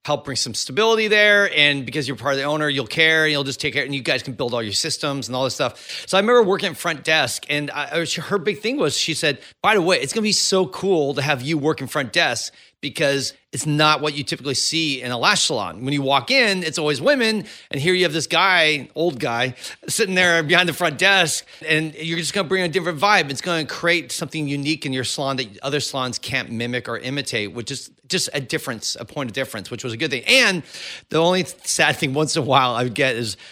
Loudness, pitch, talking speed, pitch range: -19 LUFS, 150 Hz, 260 wpm, 135-175 Hz